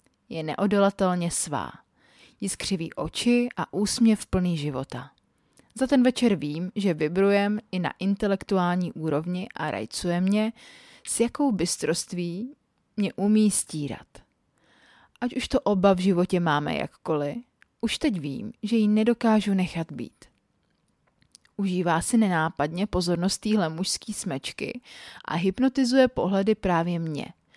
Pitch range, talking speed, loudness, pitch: 175-225 Hz, 125 wpm, -25 LUFS, 195 Hz